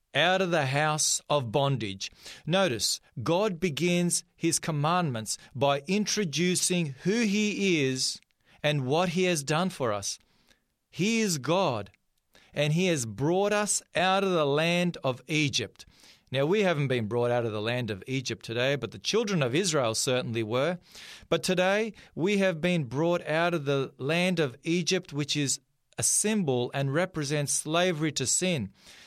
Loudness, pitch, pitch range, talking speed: -27 LUFS, 155 Hz, 130-180 Hz, 160 wpm